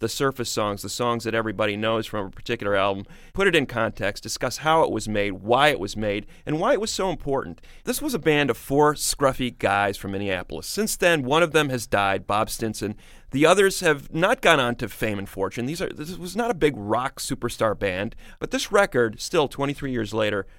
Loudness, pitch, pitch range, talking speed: -23 LUFS, 120 Hz, 105-150 Hz, 225 wpm